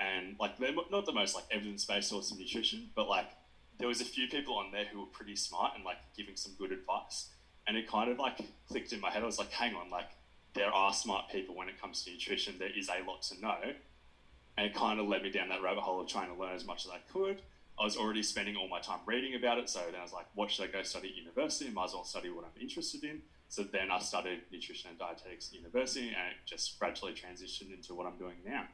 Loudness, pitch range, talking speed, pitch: -38 LUFS, 90-125 Hz, 270 wpm, 105 Hz